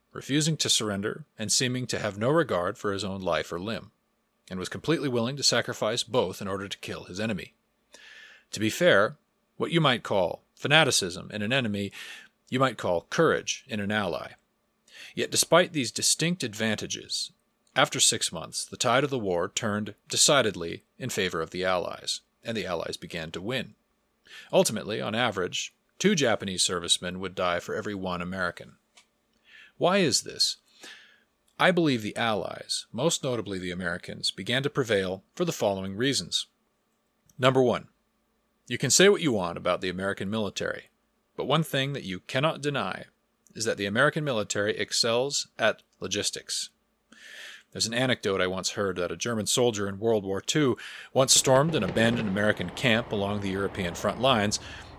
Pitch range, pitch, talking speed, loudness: 95-135 Hz, 110 Hz, 170 wpm, -27 LUFS